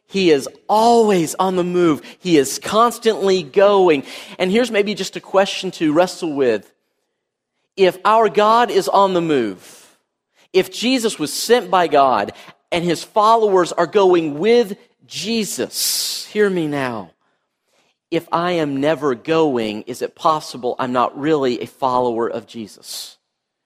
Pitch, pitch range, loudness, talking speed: 180 Hz, 150-210 Hz, -17 LUFS, 145 wpm